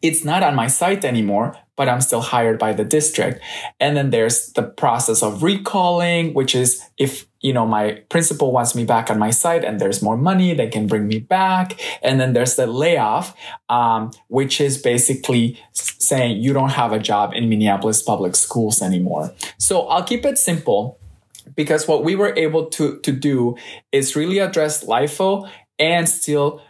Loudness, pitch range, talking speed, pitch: -18 LUFS, 115-160 Hz, 180 wpm, 135 Hz